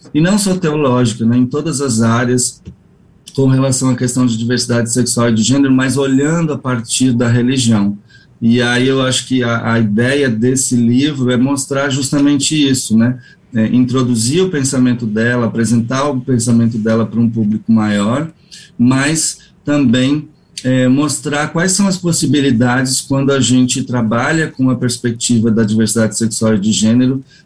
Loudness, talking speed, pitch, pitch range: -13 LUFS, 160 wpm, 125 Hz, 115-140 Hz